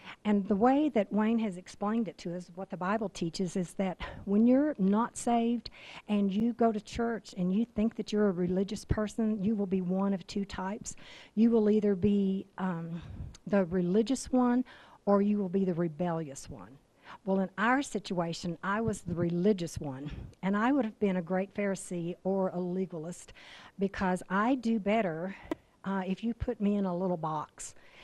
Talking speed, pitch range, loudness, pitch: 190 wpm, 185-215 Hz, -31 LUFS, 200 Hz